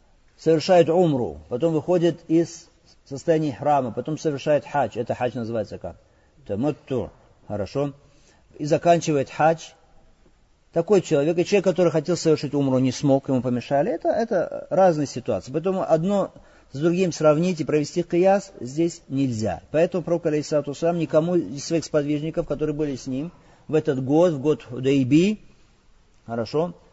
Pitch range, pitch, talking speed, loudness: 135-170 Hz, 155 Hz, 145 wpm, -23 LUFS